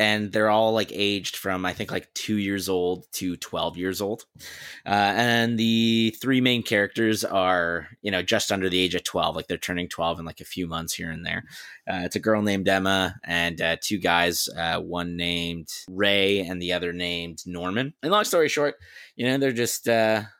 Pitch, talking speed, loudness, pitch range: 100 Hz, 210 wpm, -24 LUFS, 90-110 Hz